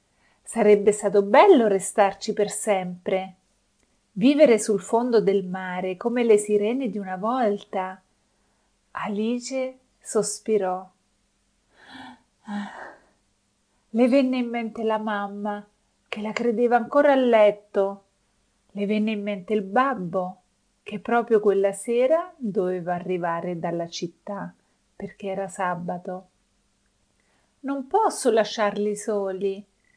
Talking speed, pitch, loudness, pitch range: 105 wpm, 205 Hz, -23 LUFS, 195-230 Hz